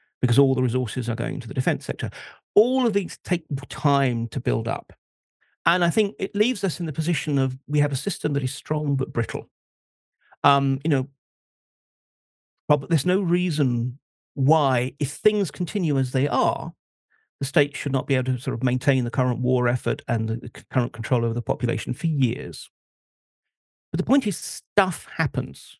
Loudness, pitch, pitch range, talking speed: -24 LUFS, 140 Hz, 125-165 Hz, 185 wpm